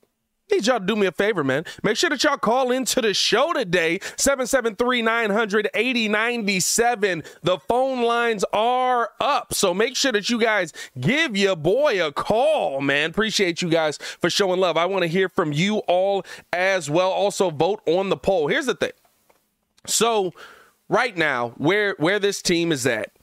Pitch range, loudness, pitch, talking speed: 180-235 Hz, -21 LUFS, 205 Hz, 180 wpm